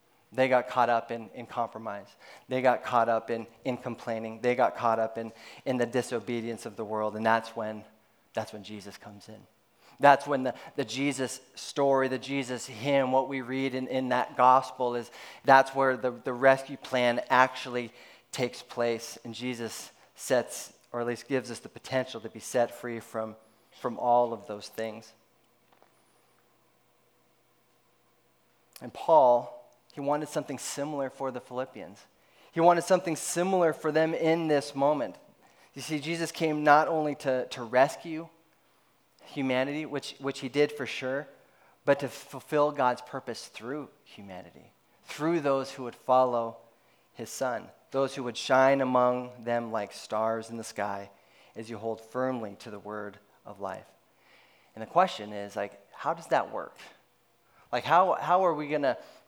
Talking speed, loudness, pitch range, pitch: 165 wpm, -29 LUFS, 115-140 Hz, 125 Hz